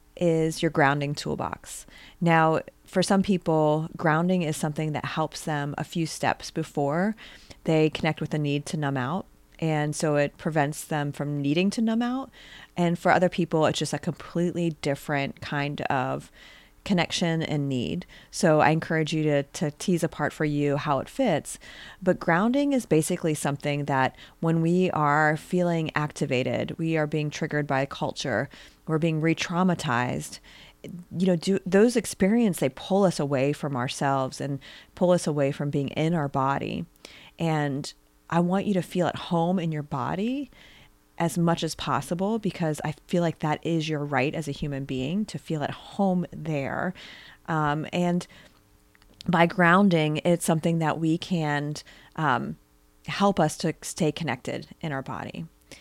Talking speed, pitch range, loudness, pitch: 165 wpm, 145-175 Hz, -26 LUFS, 160 Hz